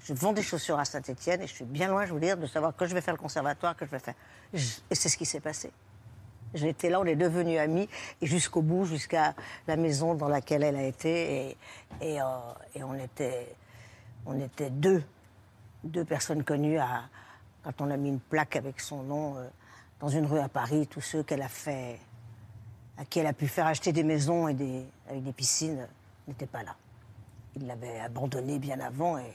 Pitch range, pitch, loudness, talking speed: 120-160 Hz, 145 Hz, -31 LUFS, 215 wpm